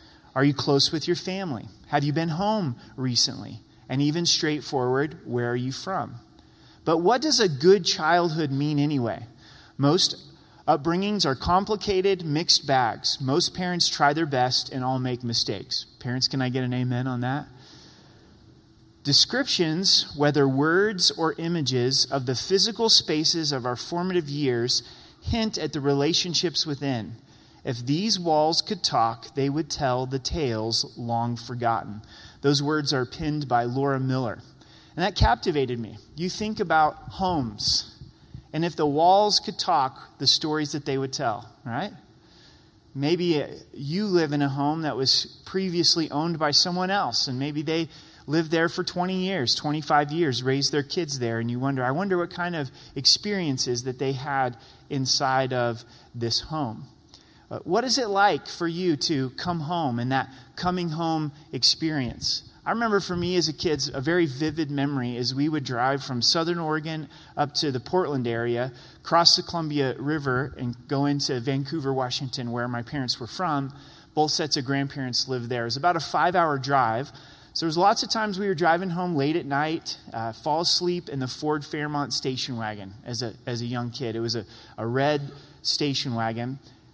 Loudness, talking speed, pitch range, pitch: -24 LUFS, 170 wpm, 125-165 Hz, 145 Hz